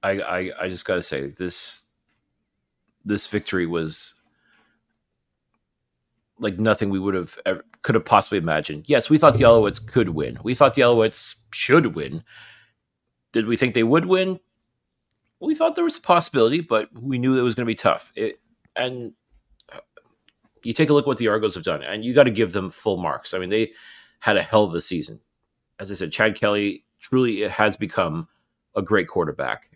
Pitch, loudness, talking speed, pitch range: 115 Hz, -21 LUFS, 190 wpm, 100-135 Hz